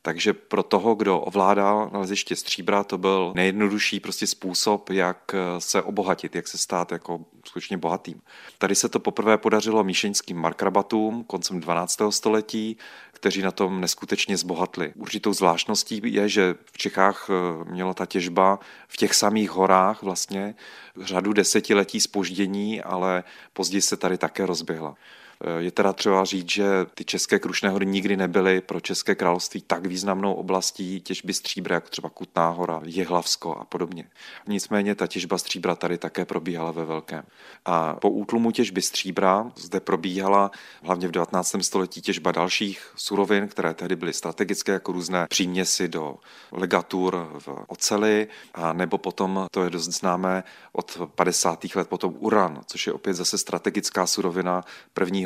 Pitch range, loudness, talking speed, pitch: 90-100 Hz, -24 LUFS, 150 wpm, 95 Hz